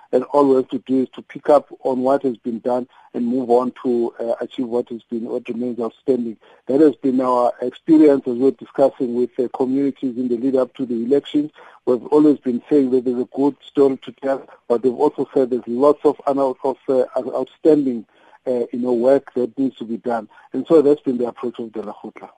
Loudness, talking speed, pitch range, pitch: -19 LUFS, 225 wpm, 120-140 Hz, 130 Hz